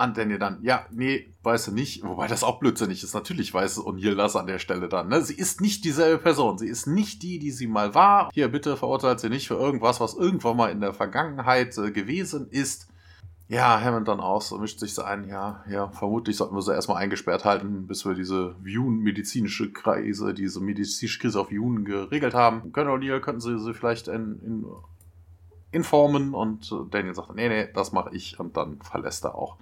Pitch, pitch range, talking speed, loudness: 115 Hz, 100-135 Hz, 210 wpm, -25 LUFS